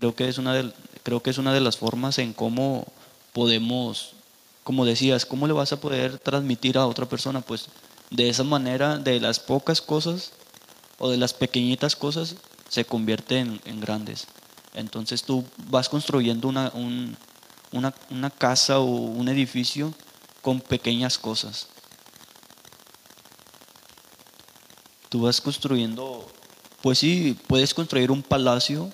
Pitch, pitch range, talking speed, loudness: 130 Hz, 120-135 Hz, 140 wpm, -24 LUFS